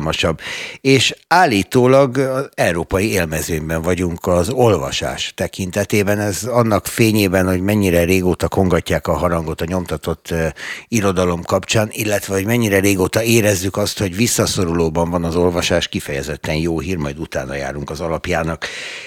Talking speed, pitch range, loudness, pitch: 130 wpm, 85-105 Hz, -17 LUFS, 95 Hz